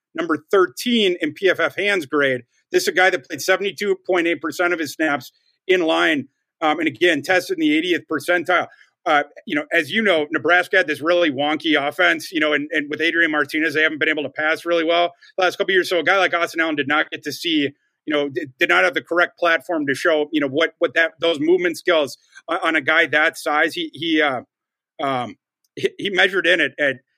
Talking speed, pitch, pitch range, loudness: 230 wpm, 170 Hz, 155-185 Hz, -19 LUFS